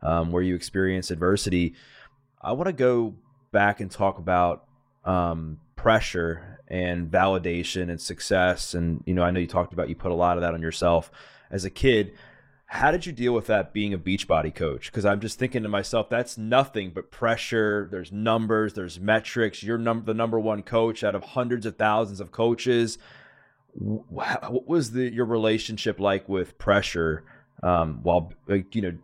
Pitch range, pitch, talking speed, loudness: 90-115 Hz, 100 Hz, 185 wpm, -25 LUFS